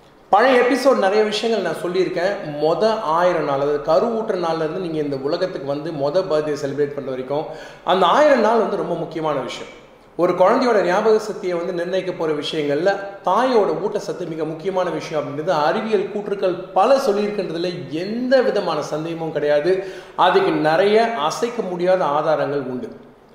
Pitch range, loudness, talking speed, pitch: 155-200 Hz, -19 LUFS, 145 wpm, 180 Hz